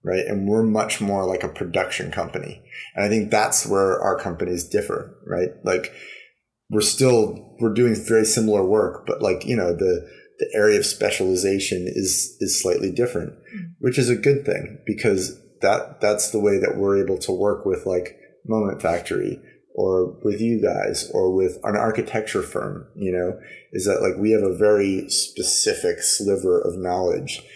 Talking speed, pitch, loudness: 175 wpm, 110 Hz, -21 LUFS